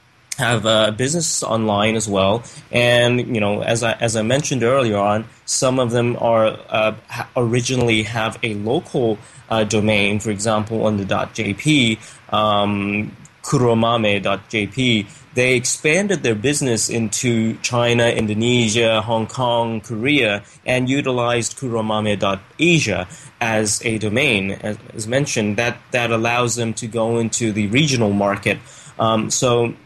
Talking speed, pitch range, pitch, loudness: 135 wpm, 110-120 Hz, 115 Hz, -18 LUFS